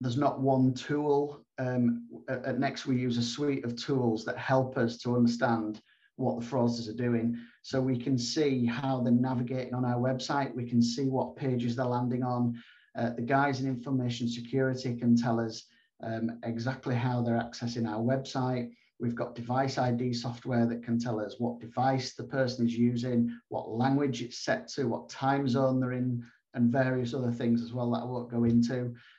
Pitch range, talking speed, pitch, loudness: 120-130 Hz, 190 wpm, 125 Hz, -31 LUFS